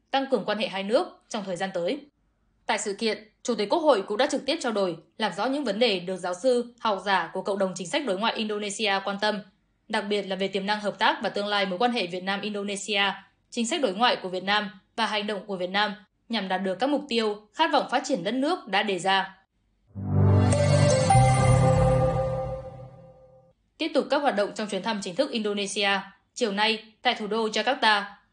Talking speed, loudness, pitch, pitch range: 220 wpm, -26 LUFS, 205 Hz, 190-225 Hz